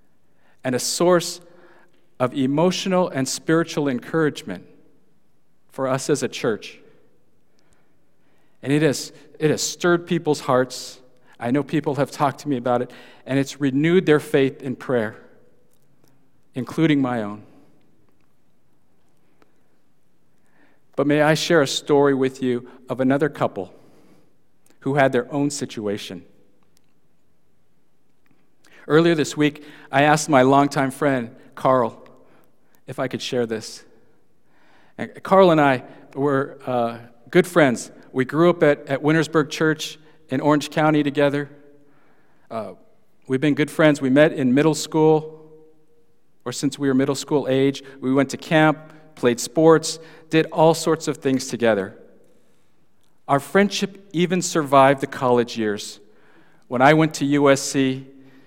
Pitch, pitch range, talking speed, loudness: 145 Hz, 130-155 Hz, 130 wpm, -20 LUFS